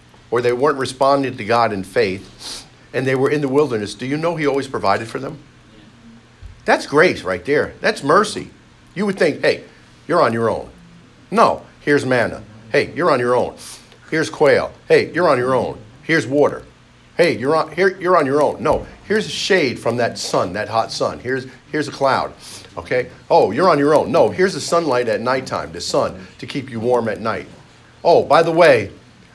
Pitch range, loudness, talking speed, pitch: 115-145 Hz, -18 LUFS, 200 wpm, 130 Hz